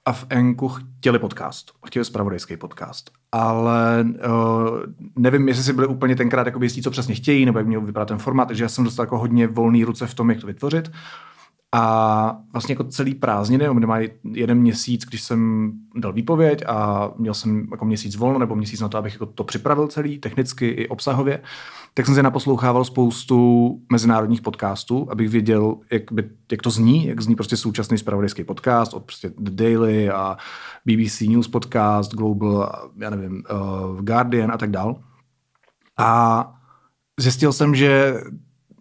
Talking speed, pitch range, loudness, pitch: 170 wpm, 110-125 Hz, -20 LUFS, 115 Hz